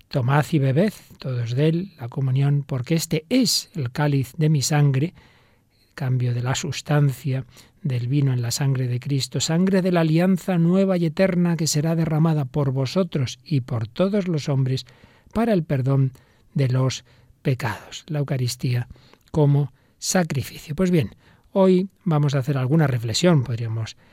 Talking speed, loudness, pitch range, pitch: 160 wpm, -22 LUFS, 125-165 Hz, 140 Hz